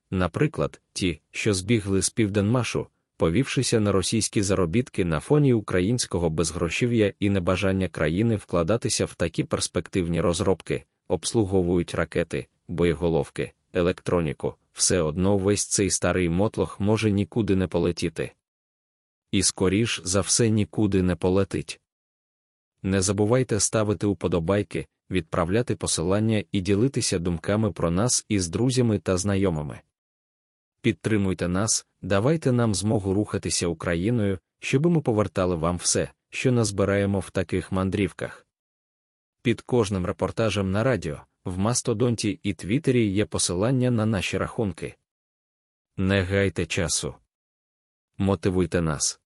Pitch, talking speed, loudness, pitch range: 100 Hz, 115 wpm, -24 LUFS, 90-110 Hz